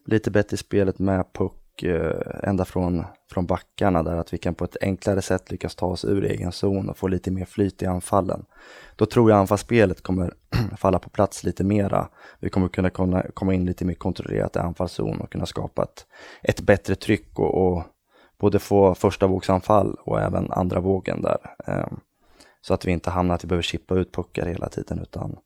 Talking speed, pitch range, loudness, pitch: 195 wpm, 90-100 Hz, -24 LUFS, 95 Hz